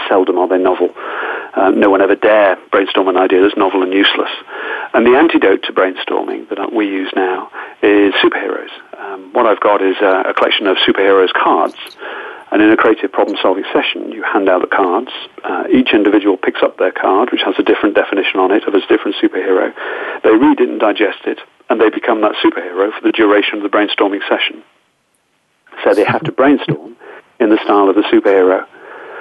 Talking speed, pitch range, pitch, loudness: 195 wpm, 300-445 Hz, 365 Hz, -13 LUFS